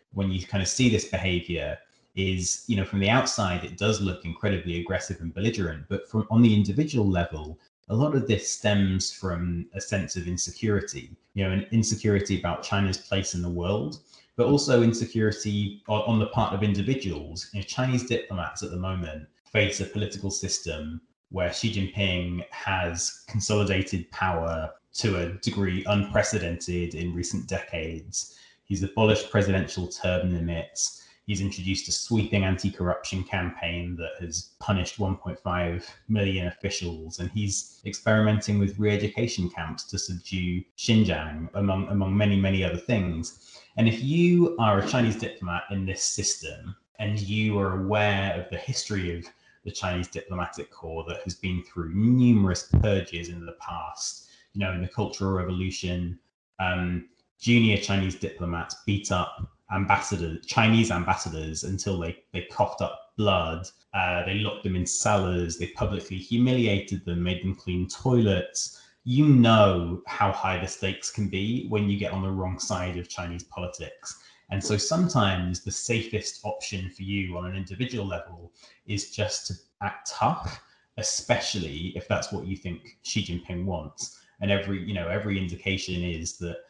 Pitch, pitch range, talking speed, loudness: 95 Hz, 90-105 Hz, 160 wpm, -27 LUFS